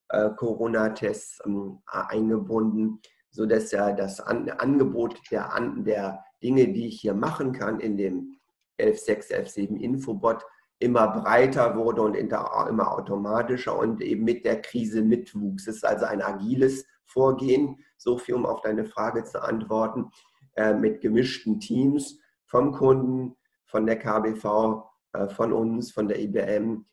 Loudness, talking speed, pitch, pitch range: -26 LUFS, 125 wpm, 115 Hz, 110-130 Hz